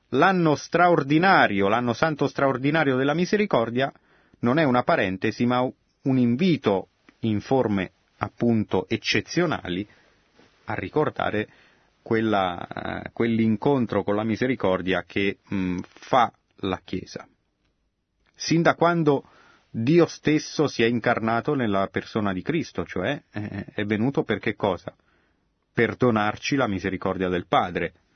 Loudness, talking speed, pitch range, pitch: -24 LUFS, 120 wpm, 100-140 Hz, 115 Hz